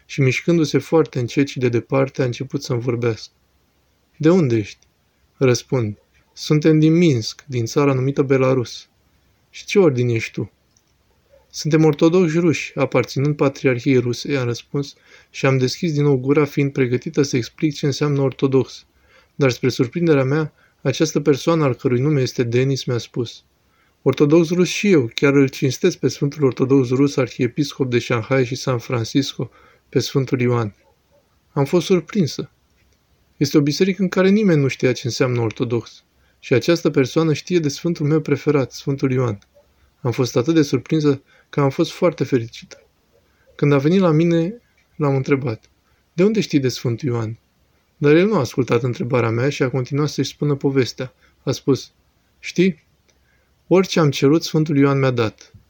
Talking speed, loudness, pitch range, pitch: 165 wpm, -19 LUFS, 125-155 Hz, 140 Hz